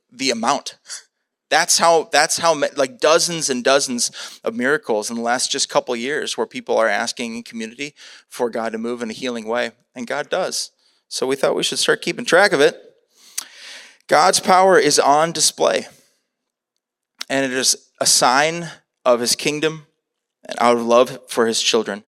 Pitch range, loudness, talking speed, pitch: 120-170 Hz, -18 LUFS, 180 wpm, 145 Hz